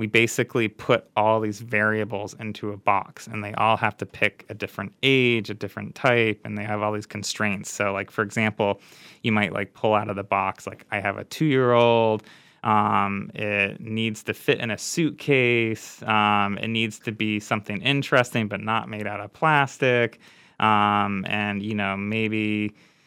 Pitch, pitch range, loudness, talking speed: 110 Hz, 105-115 Hz, -23 LUFS, 180 wpm